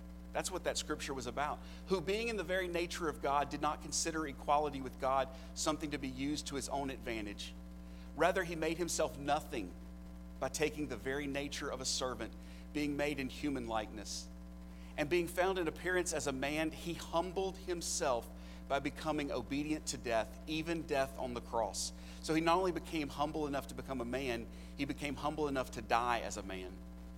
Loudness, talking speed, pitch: -38 LUFS, 190 wpm, 145 Hz